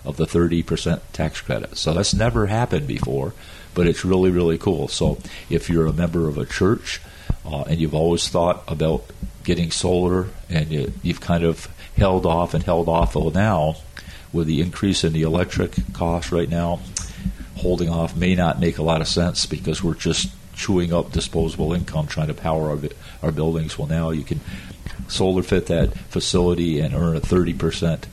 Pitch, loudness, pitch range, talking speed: 85 Hz, -21 LUFS, 80-90 Hz, 185 wpm